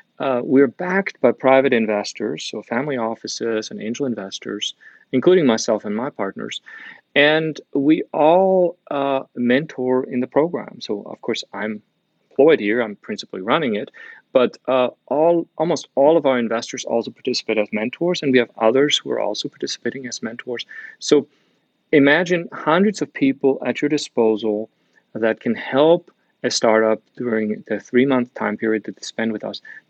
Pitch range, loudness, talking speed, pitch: 110-155 Hz, -20 LUFS, 160 wpm, 130 Hz